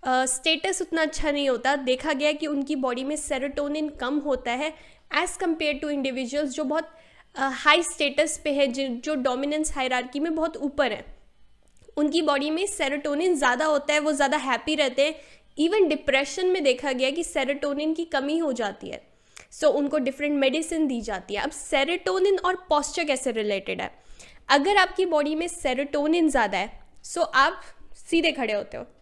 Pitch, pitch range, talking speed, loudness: 295 Hz, 275-315 Hz, 185 wpm, -25 LUFS